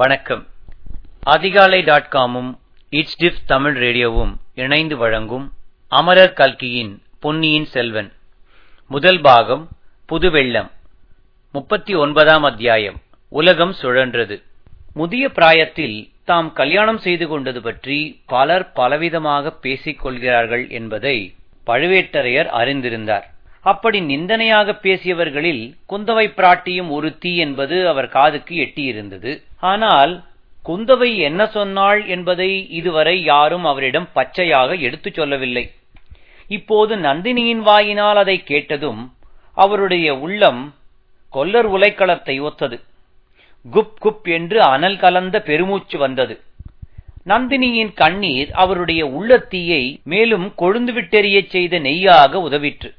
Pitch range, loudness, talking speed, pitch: 130-190 Hz, -15 LUFS, 95 wpm, 155 Hz